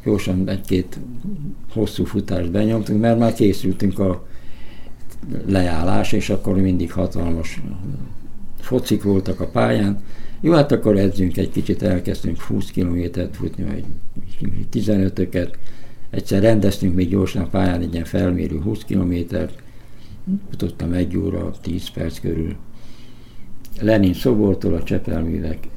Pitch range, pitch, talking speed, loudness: 90-110 Hz, 100 Hz, 120 wpm, -21 LUFS